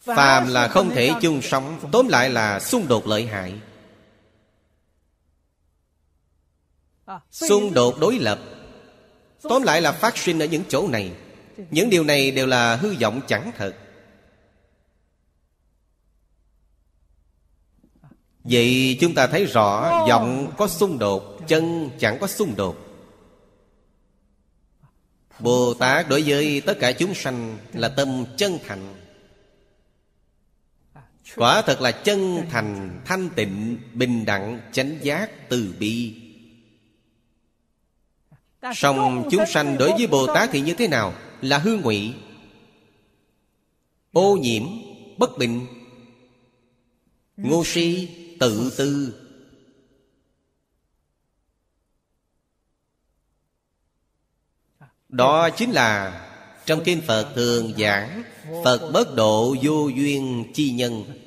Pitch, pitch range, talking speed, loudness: 120 Hz, 100-145 Hz, 110 wpm, -21 LUFS